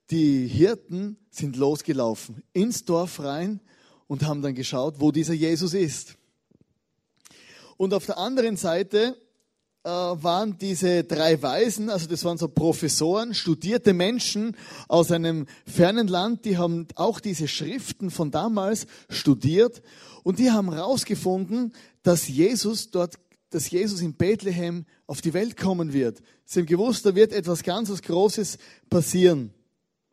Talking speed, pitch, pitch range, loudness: 135 wpm, 180 Hz, 160-210 Hz, -24 LUFS